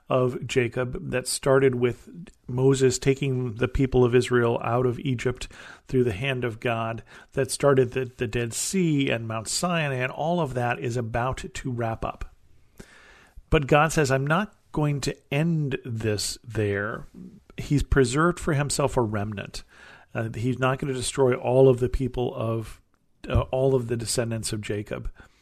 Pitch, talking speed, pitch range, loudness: 130 Hz, 170 wpm, 120-140 Hz, -25 LUFS